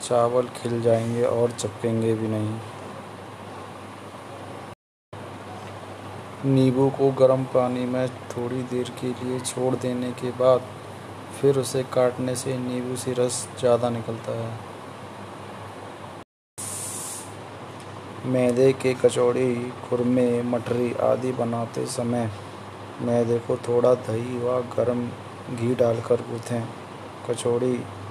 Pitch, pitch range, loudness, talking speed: 120 Hz, 110-125 Hz, -24 LUFS, 100 wpm